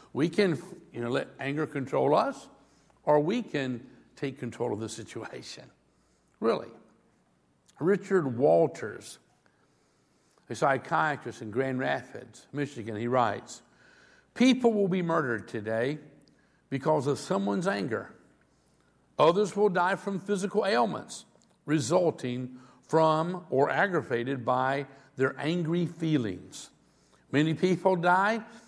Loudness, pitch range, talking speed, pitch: -28 LUFS, 120-180 Hz, 110 wpm, 145 Hz